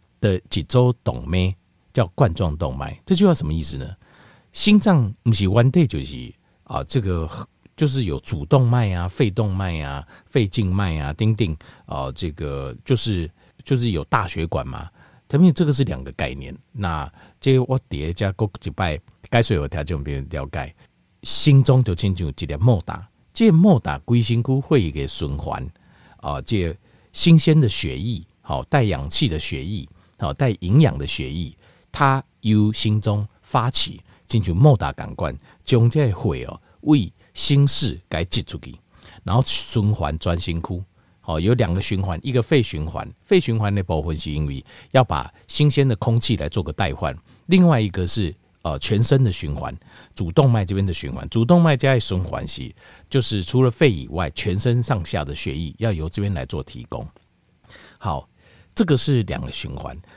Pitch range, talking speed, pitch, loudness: 85-125 Hz, 250 characters per minute, 105 Hz, -20 LUFS